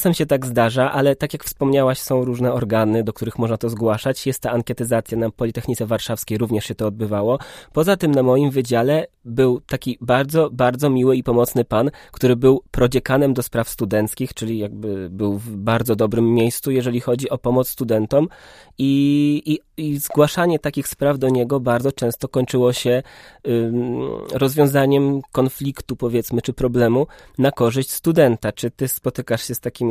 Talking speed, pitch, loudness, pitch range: 170 wpm, 125 Hz, -19 LUFS, 115-135 Hz